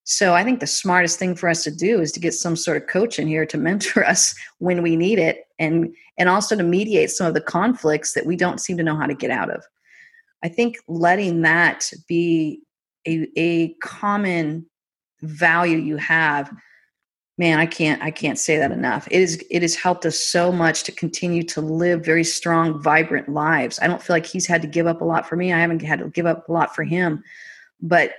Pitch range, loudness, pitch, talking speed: 160-180 Hz, -20 LUFS, 165 Hz, 225 wpm